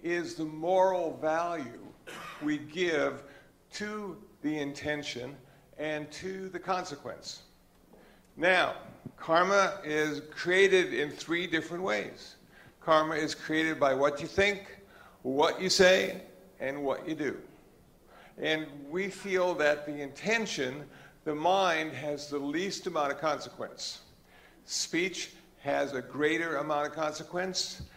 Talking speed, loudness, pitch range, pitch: 120 wpm, -30 LUFS, 150-185 Hz, 155 Hz